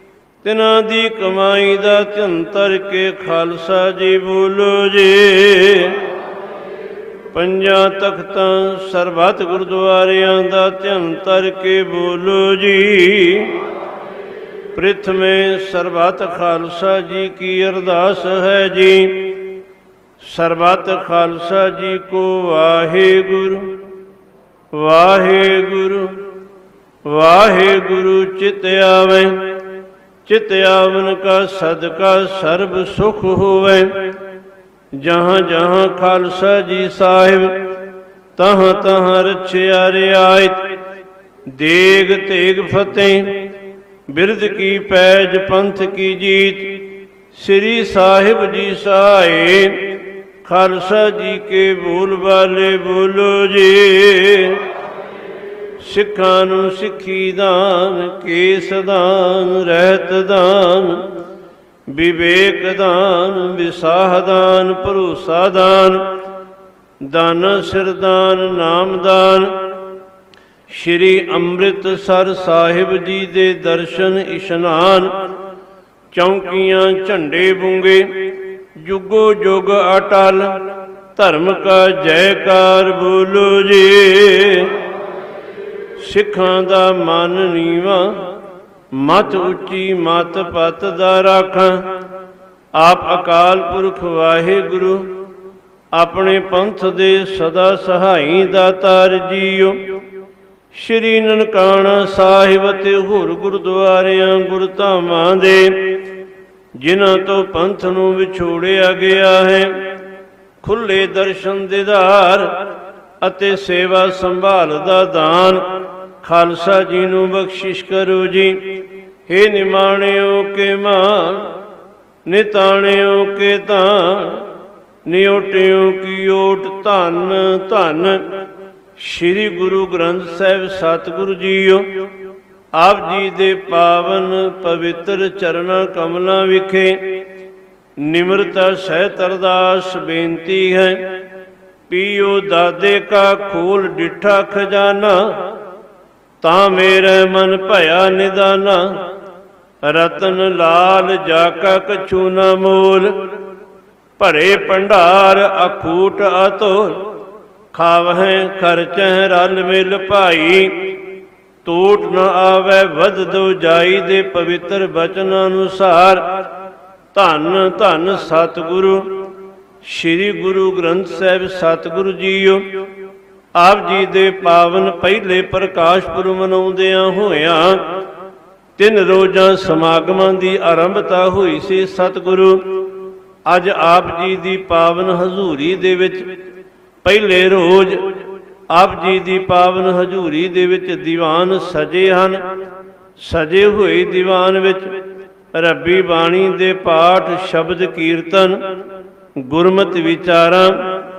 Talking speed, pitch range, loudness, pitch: 85 wpm, 185-195 Hz, -12 LUFS, 190 Hz